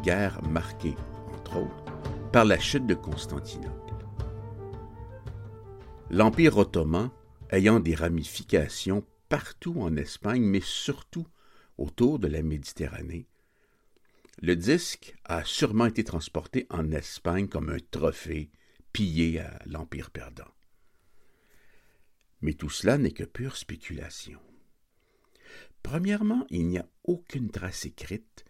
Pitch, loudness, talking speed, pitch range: 100 Hz, -29 LUFS, 110 wpm, 80-110 Hz